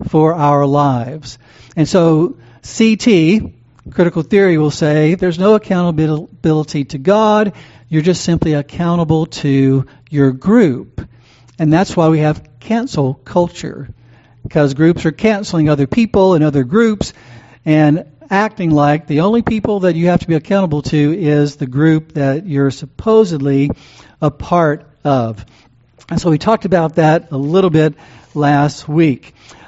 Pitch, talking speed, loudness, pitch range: 155 Hz, 145 wpm, -14 LUFS, 140-175 Hz